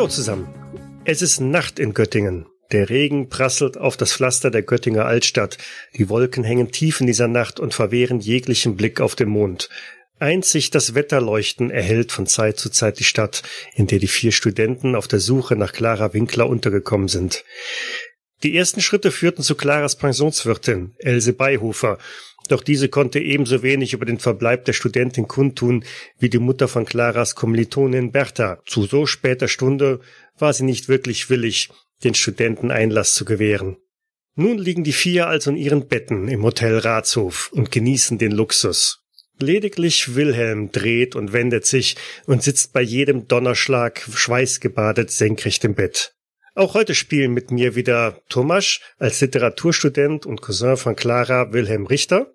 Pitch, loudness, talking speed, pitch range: 125 Hz, -18 LUFS, 160 wpm, 115-140 Hz